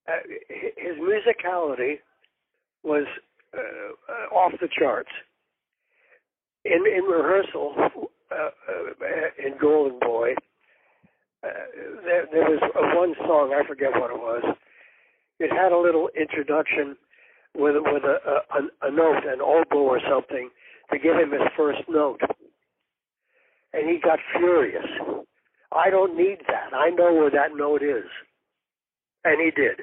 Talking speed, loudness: 135 wpm, -23 LUFS